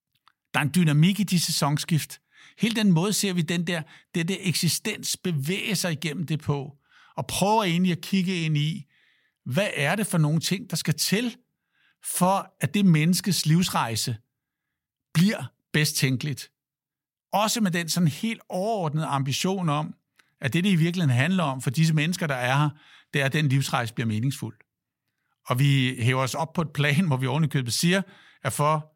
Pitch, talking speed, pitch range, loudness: 160 Hz, 185 wpm, 140-185 Hz, -25 LUFS